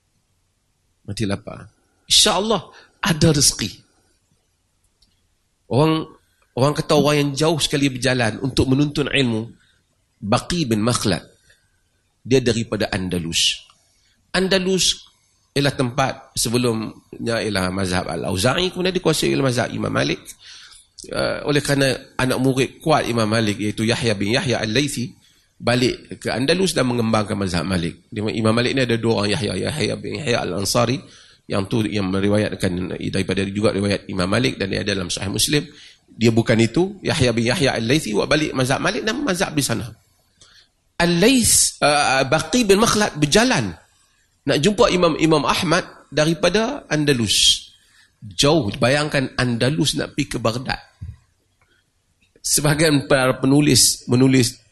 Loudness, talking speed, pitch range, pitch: -19 LUFS, 135 wpm, 100-145 Hz, 120 Hz